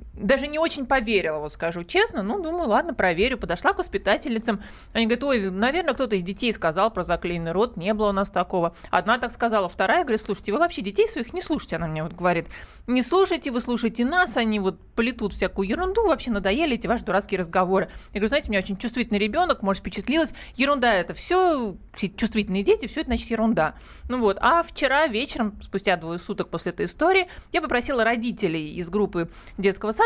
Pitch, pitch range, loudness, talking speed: 225 Hz, 195-270 Hz, -24 LUFS, 200 wpm